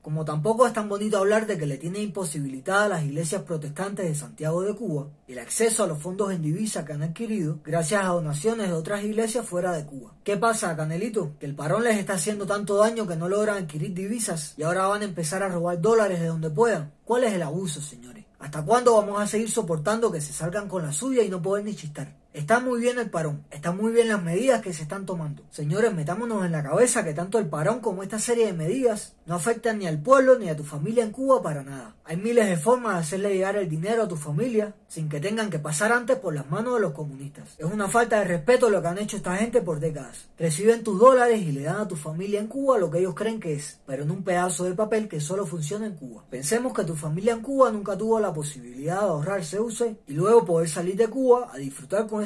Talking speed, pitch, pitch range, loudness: 245 wpm, 195 Hz, 160-220 Hz, -25 LUFS